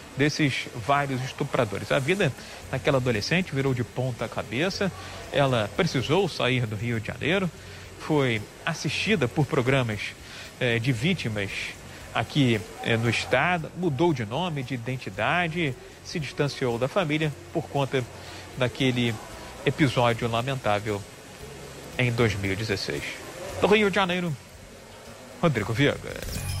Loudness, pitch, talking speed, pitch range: -26 LUFS, 130 Hz, 115 wpm, 110-150 Hz